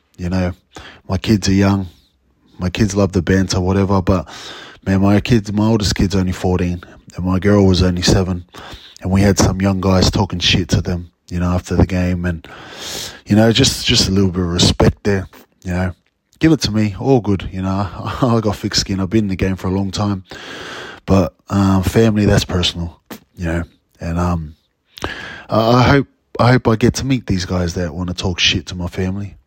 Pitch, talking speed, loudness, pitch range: 95 Hz, 210 wpm, -16 LUFS, 90-105 Hz